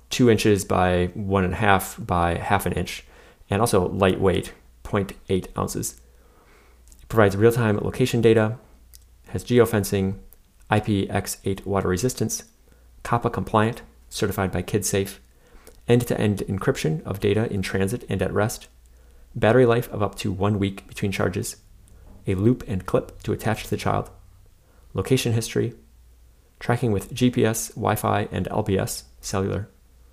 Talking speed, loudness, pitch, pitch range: 135 wpm, -23 LUFS, 100 Hz, 90-110 Hz